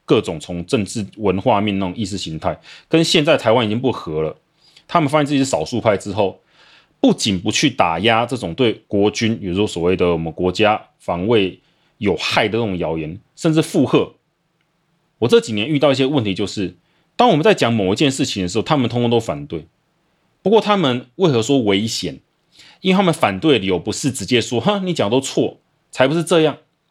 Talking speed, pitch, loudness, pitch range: 305 characters per minute, 125 Hz, -18 LUFS, 100-160 Hz